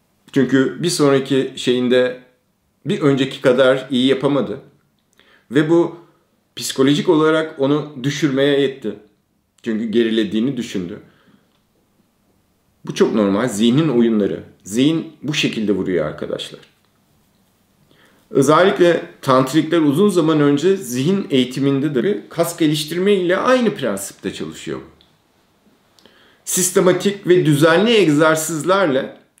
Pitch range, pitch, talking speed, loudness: 125-170 Hz, 140 Hz, 95 wpm, -17 LUFS